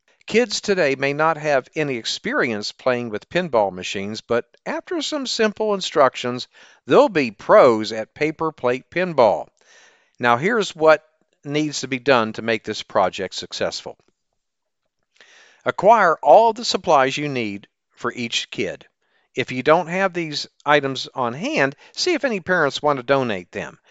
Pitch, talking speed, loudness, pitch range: 145 Hz, 150 wpm, -20 LUFS, 120-180 Hz